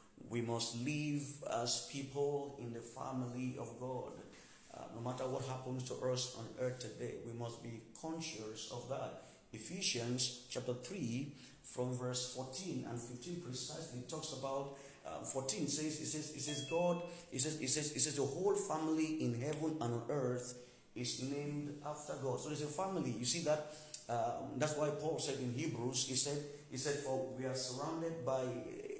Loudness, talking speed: -39 LUFS, 180 wpm